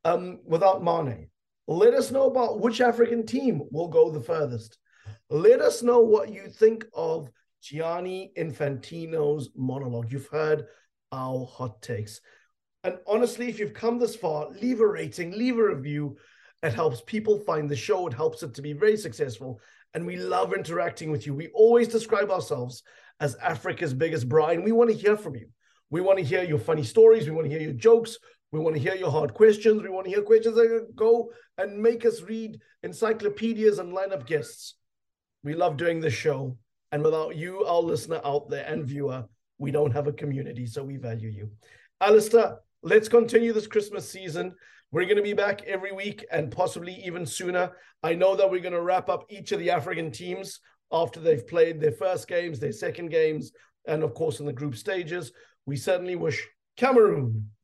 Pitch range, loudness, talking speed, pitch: 145-215 Hz, -25 LUFS, 190 wpm, 170 Hz